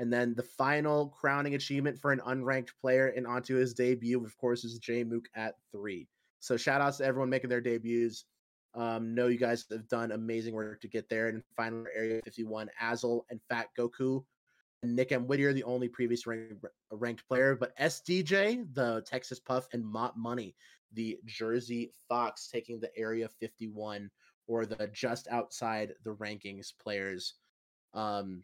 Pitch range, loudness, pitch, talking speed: 115-130 Hz, -34 LUFS, 120 Hz, 170 wpm